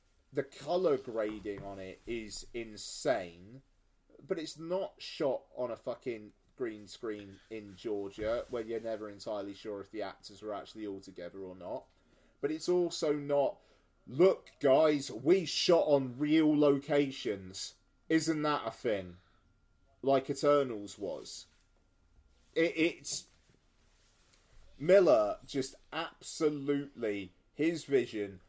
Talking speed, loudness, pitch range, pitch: 120 wpm, -33 LUFS, 100-145 Hz, 110 Hz